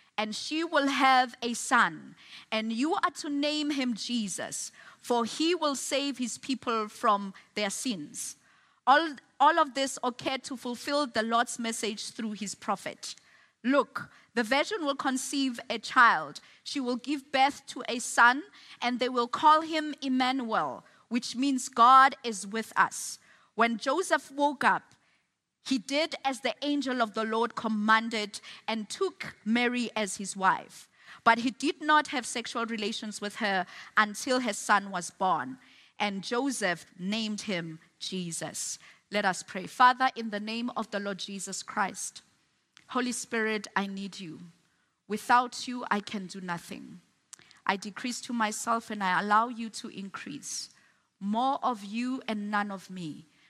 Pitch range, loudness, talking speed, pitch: 210-265 Hz, -29 LUFS, 155 wpm, 235 Hz